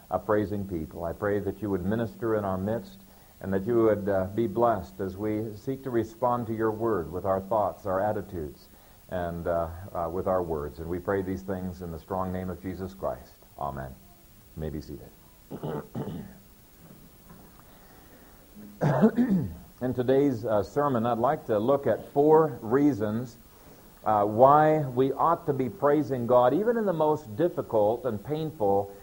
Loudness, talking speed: -27 LUFS, 165 wpm